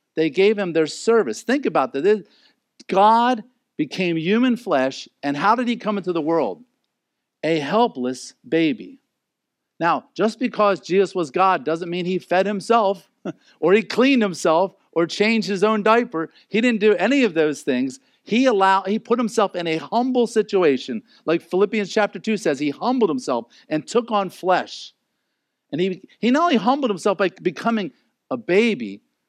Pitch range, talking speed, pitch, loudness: 175-230 Hz, 170 wpm, 205 Hz, -20 LUFS